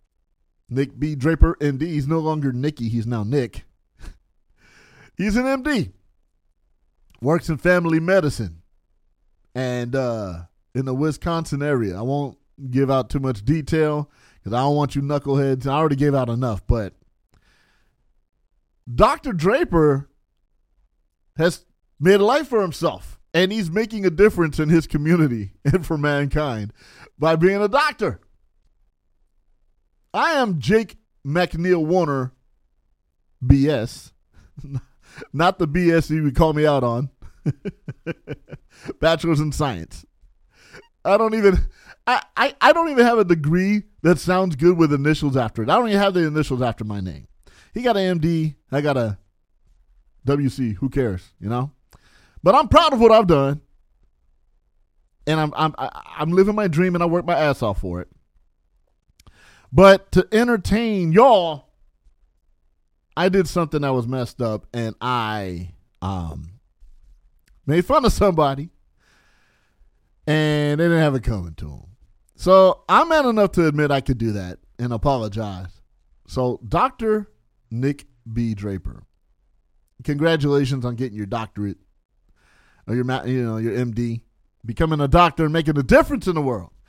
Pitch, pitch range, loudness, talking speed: 140 Hz, 105-165 Hz, -20 LUFS, 145 wpm